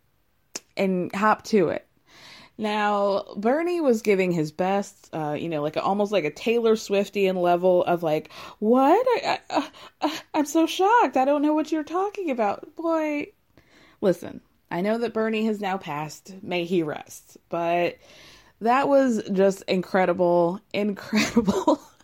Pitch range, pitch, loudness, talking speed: 180-275 Hz, 205 Hz, -24 LUFS, 145 wpm